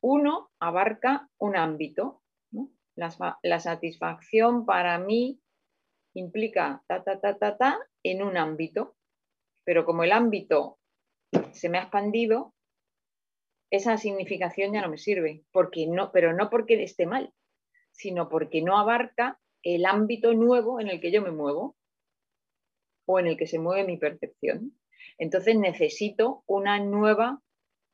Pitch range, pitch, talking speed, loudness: 170-230 Hz, 200 Hz, 140 wpm, -26 LUFS